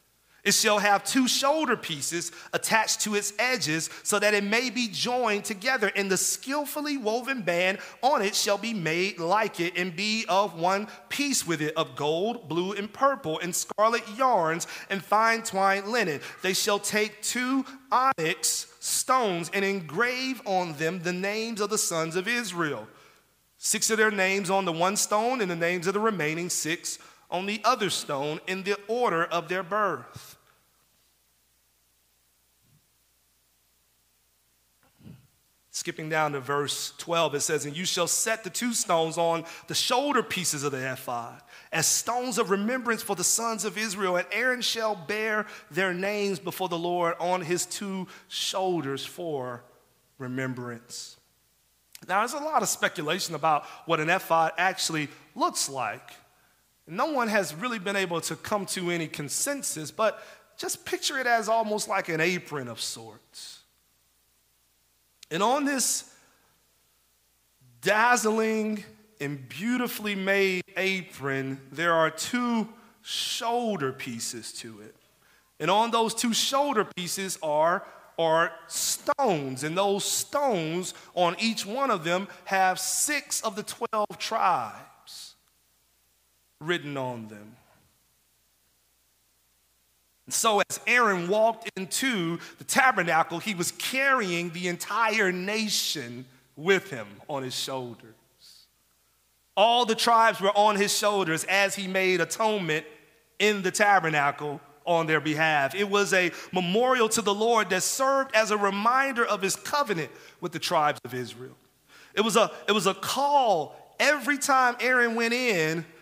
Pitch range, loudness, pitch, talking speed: 155-220 Hz, -26 LUFS, 185 Hz, 145 wpm